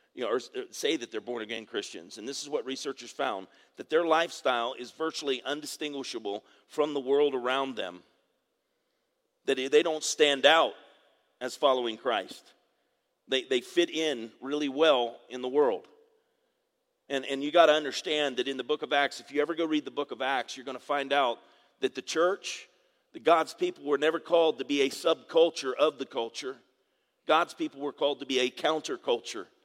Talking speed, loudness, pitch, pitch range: 190 wpm, -29 LUFS, 150 Hz, 135-170 Hz